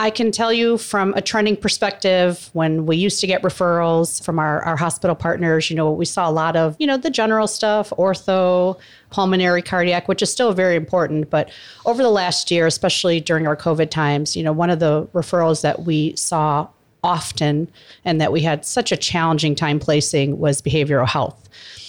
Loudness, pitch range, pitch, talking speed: -18 LUFS, 155-190 Hz, 170 Hz, 195 wpm